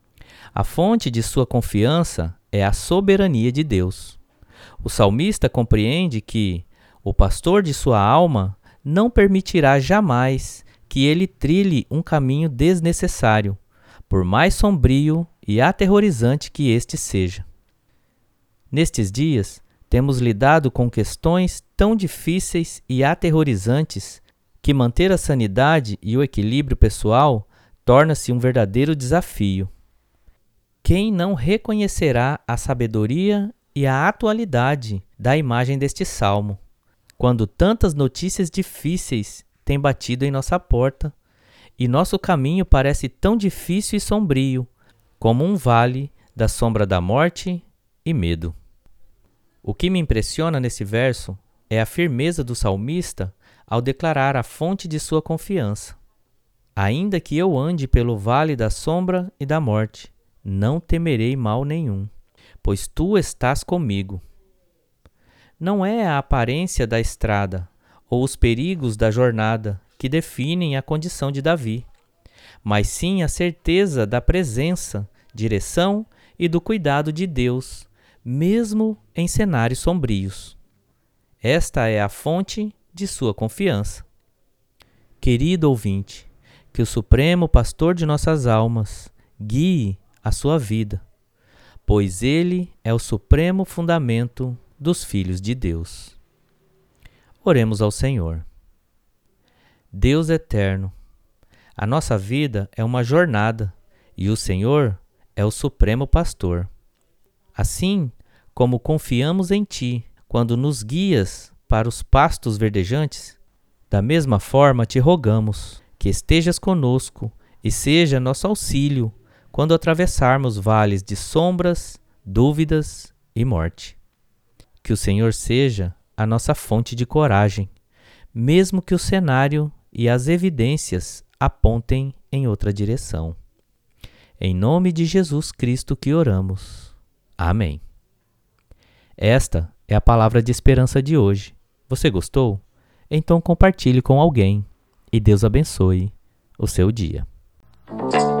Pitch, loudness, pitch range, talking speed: 120 Hz, -20 LUFS, 105-155 Hz, 120 wpm